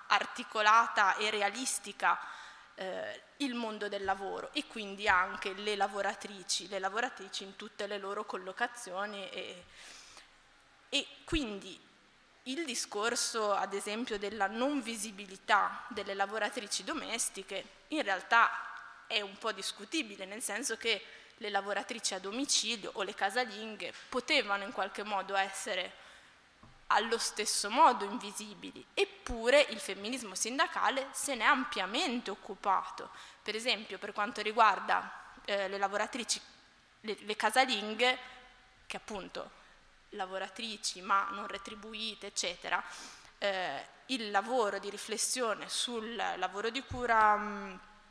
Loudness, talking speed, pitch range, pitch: -33 LUFS, 120 wpm, 200-240 Hz, 210 Hz